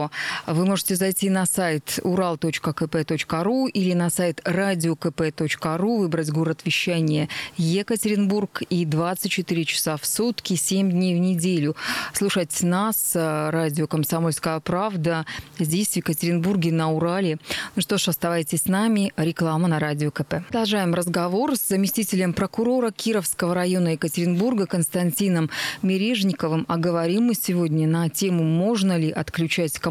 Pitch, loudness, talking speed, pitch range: 175 Hz, -23 LUFS, 125 wpm, 160-195 Hz